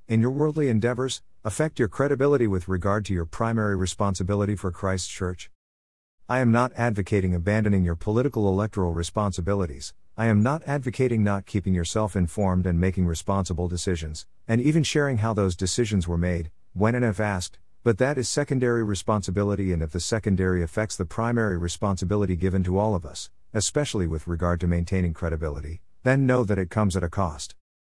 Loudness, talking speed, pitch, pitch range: -25 LUFS, 175 wpm, 100 Hz, 90-115 Hz